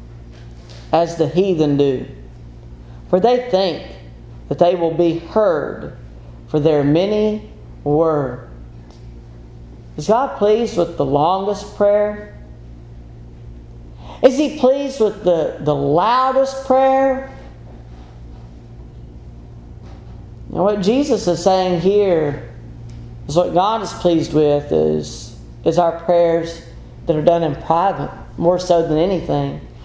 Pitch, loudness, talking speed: 155 Hz, -17 LUFS, 115 wpm